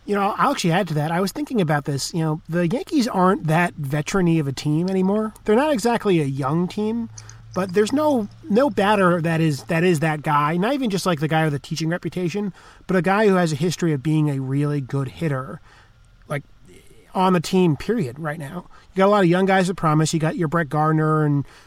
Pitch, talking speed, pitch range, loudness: 170 Hz, 235 wpm, 150-195 Hz, -21 LUFS